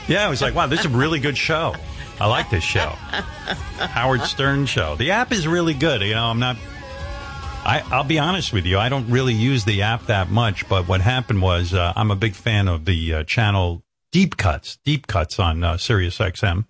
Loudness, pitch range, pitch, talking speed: -20 LUFS, 95-130 Hz, 110 Hz, 225 wpm